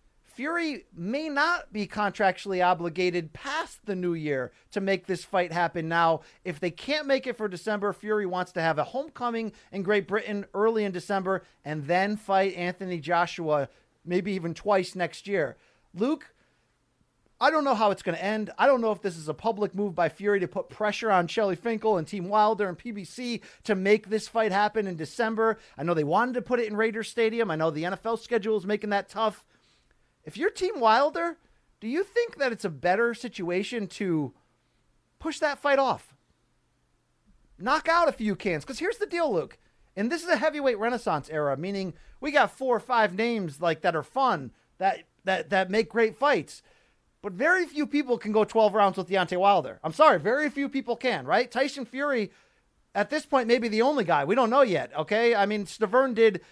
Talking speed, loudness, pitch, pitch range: 200 wpm, -27 LUFS, 210 Hz, 185-245 Hz